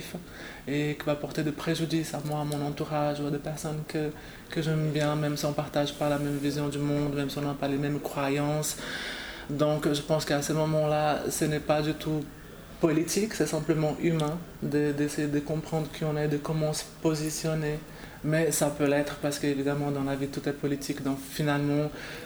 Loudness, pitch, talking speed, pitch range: -29 LUFS, 150 Hz, 215 wpm, 145-155 Hz